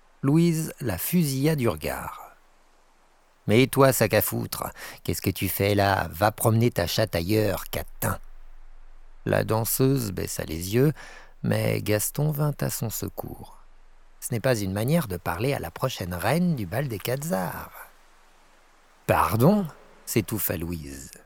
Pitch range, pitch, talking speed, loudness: 95-135 Hz, 110 Hz, 140 wpm, -25 LUFS